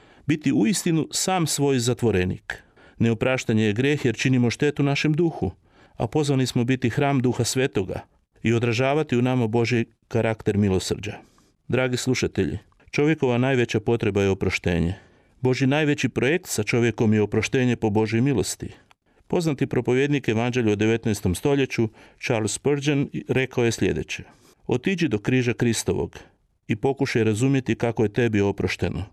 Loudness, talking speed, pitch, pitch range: -23 LUFS, 140 wpm, 120 Hz, 110-135 Hz